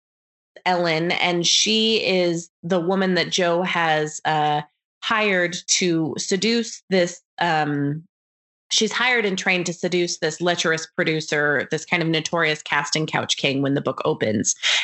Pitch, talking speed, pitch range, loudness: 175 Hz, 140 wpm, 155-185 Hz, -21 LUFS